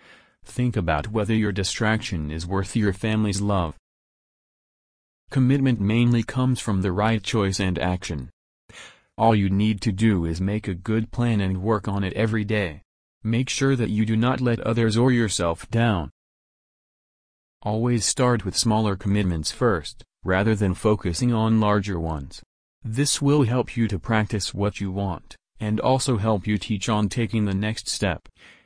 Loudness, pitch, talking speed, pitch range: -23 LUFS, 105 Hz, 160 wpm, 95-115 Hz